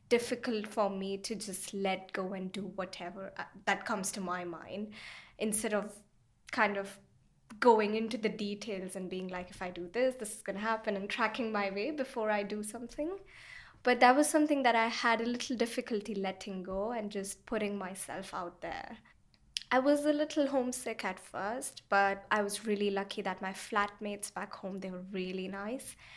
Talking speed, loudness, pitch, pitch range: 190 wpm, -34 LUFS, 210 Hz, 195-235 Hz